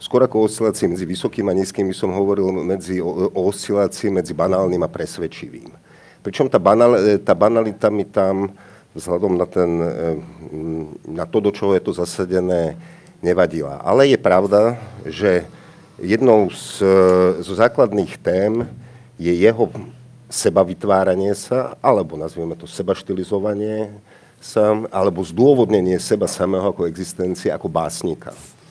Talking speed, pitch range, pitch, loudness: 130 wpm, 90-105 Hz, 95 Hz, -18 LUFS